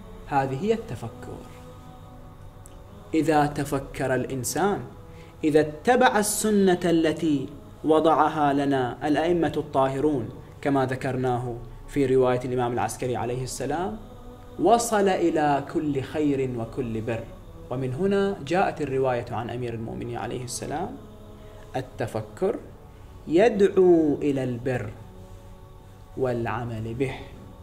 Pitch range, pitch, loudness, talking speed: 115-150 Hz, 130 Hz, -25 LUFS, 95 wpm